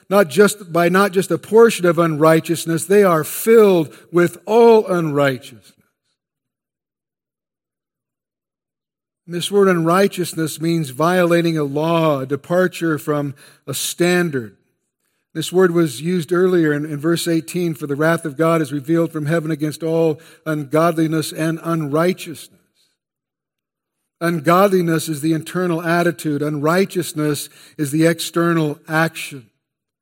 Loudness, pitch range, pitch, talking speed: -17 LUFS, 155-175 Hz, 165 Hz, 120 wpm